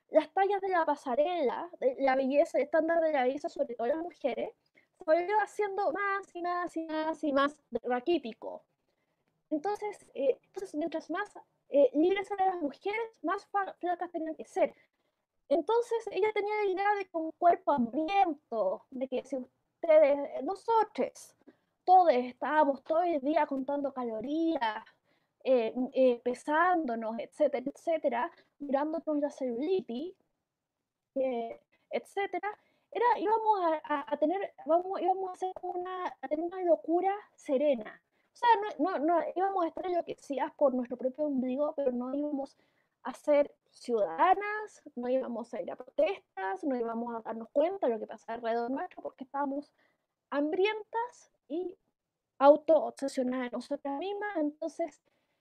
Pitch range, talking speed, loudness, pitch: 275-365 Hz, 135 wpm, -31 LUFS, 310 Hz